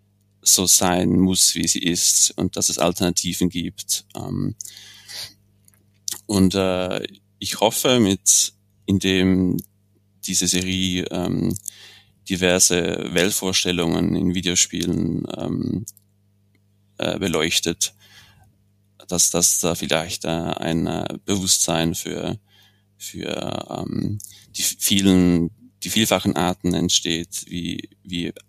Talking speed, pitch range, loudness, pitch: 80 wpm, 90-100 Hz, -20 LUFS, 95 Hz